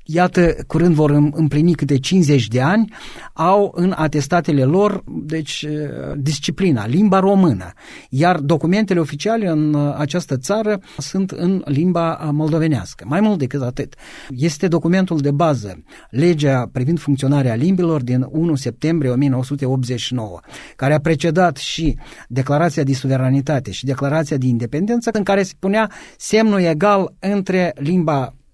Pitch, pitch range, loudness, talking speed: 155 Hz, 140-180 Hz, -17 LUFS, 130 wpm